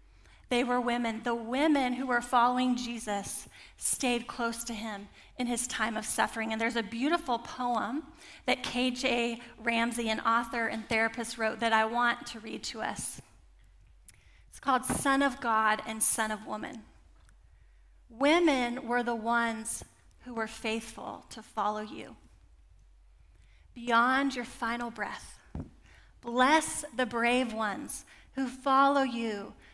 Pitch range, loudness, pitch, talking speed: 225-250 Hz, -30 LUFS, 235 Hz, 135 wpm